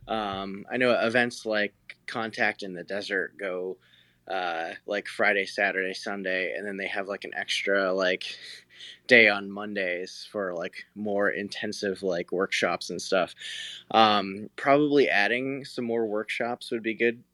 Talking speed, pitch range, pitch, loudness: 150 wpm, 95-115 Hz, 105 Hz, -27 LUFS